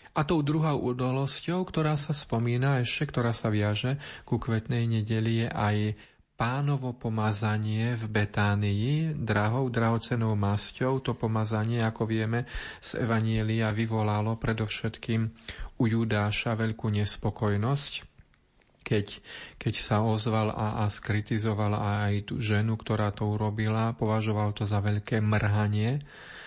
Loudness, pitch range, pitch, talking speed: -29 LUFS, 105-120 Hz, 110 Hz, 120 wpm